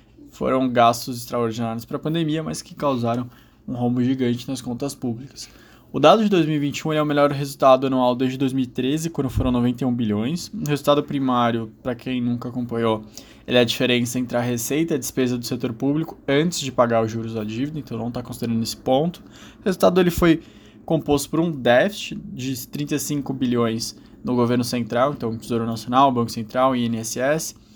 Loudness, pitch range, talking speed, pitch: -22 LUFS, 120-145 Hz, 180 wpm, 125 Hz